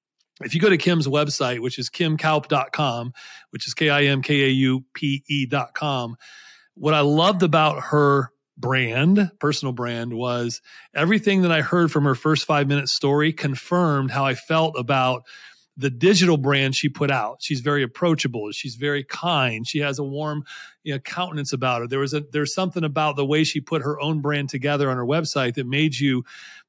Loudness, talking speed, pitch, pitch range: -21 LUFS, 190 wpm, 145 Hz, 135-155 Hz